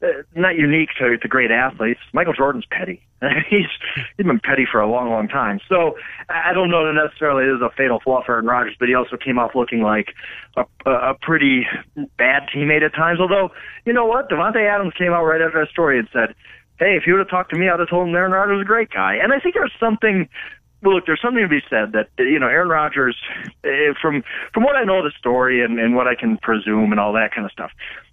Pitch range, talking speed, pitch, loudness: 125-185 Hz, 245 wpm, 155 Hz, -18 LUFS